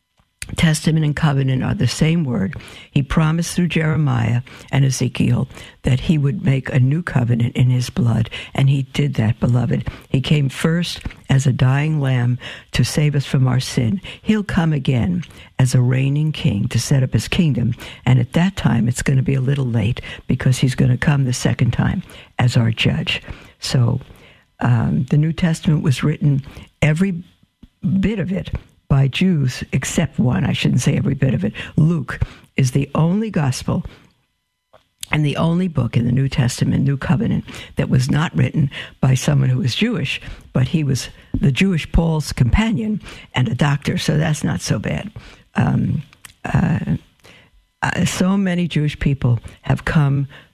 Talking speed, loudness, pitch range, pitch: 170 wpm, -19 LUFS, 125-160 Hz, 140 Hz